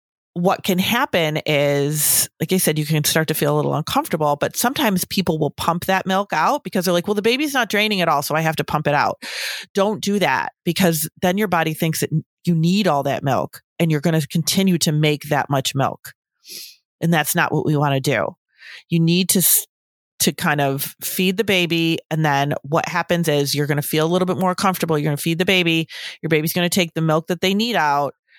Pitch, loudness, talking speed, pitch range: 165 Hz, -19 LUFS, 235 wpm, 150-185 Hz